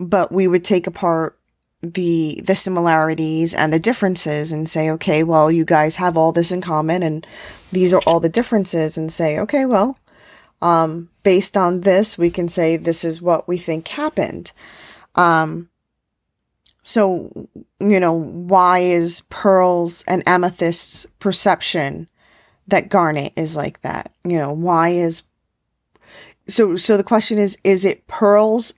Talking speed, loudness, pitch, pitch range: 150 wpm, -16 LUFS, 175 Hz, 165-195 Hz